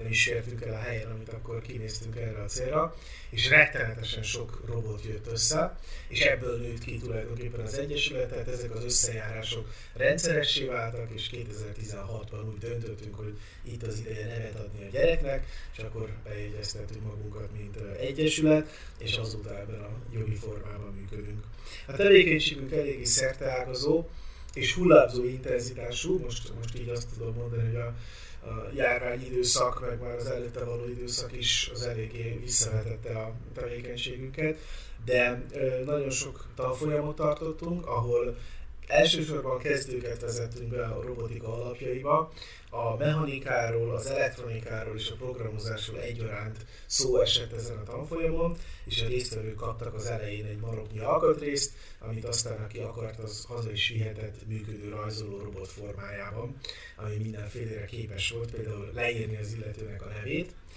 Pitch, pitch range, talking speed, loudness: 115 Hz, 110-125 Hz, 140 wpm, -29 LUFS